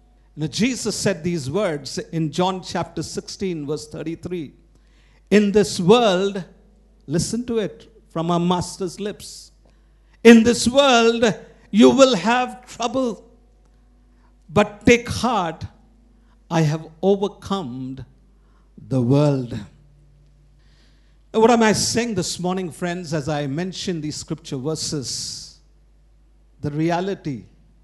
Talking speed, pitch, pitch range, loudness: 110 wpm, 180 Hz, 155-215 Hz, -20 LUFS